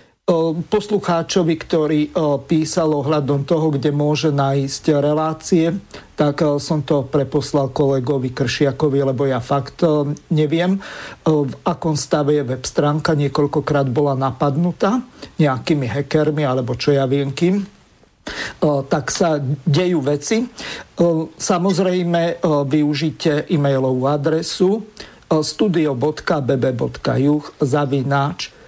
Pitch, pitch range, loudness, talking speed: 150 Hz, 140-165 Hz, -18 LUFS, 95 wpm